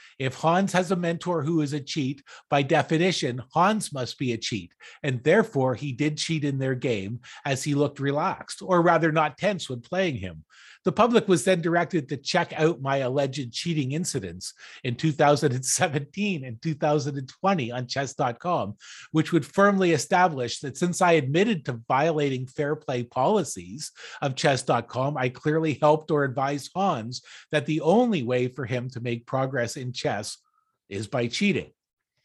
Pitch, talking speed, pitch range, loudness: 150 Hz, 165 wpm, 130-170 Hz, -25 LUFS